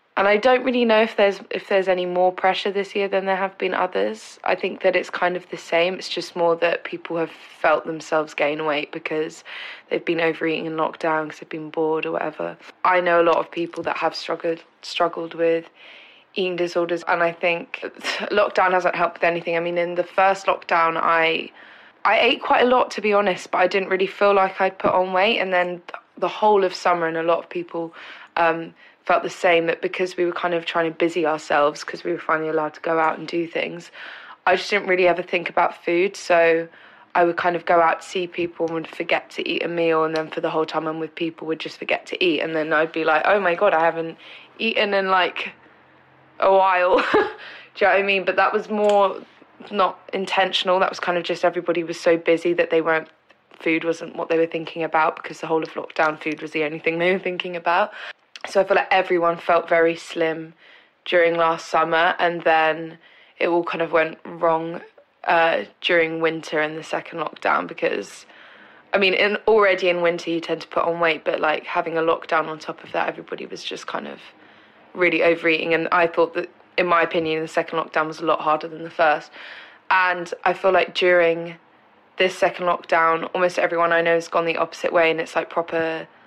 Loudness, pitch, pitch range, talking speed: -21 LUFS, 170 Hz, 165-180 Hz, 225 wpm